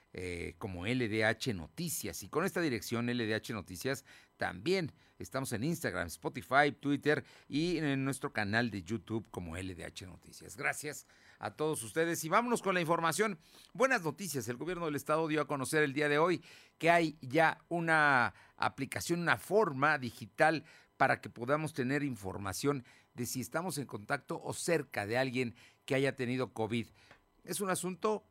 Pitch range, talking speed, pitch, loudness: 115-160 Hz, 160 wpm, 135 Hz, -34 LUFS